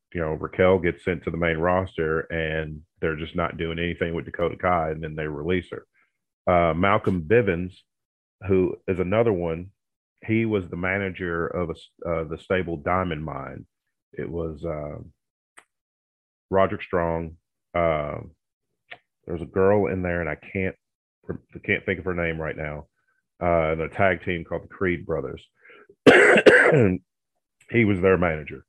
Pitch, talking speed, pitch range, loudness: 85 Hz, 160 wpm, 80-95 Hz, -23 LUFS